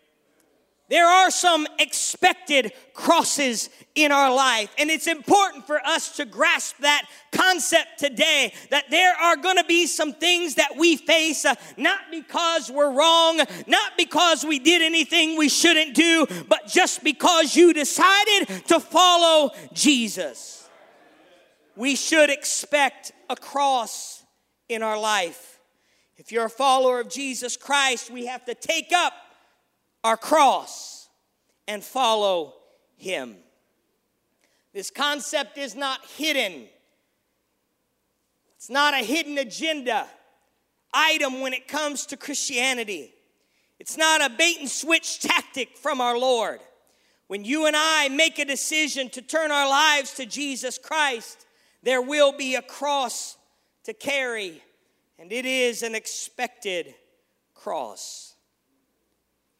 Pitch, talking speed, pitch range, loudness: 290 Hz, 130 wpm, 260-325 Hz, -21 LUFS